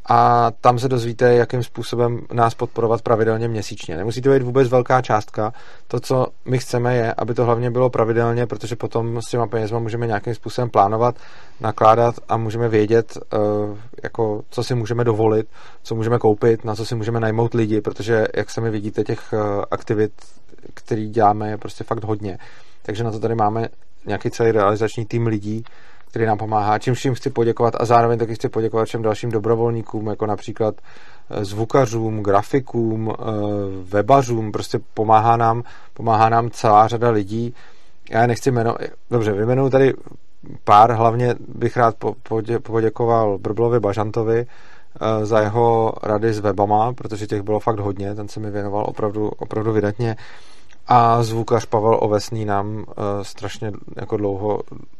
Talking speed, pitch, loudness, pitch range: 155 wpm, 115 Hz, -19 LUFS, 110-120 Hz